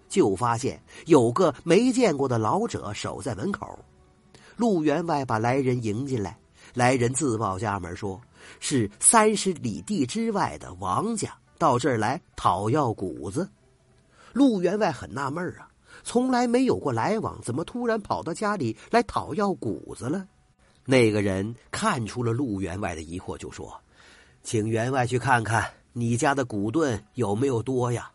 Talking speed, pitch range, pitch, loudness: 230 characters per minute, 110-180 Hz, 125 Hz, -25 LUFS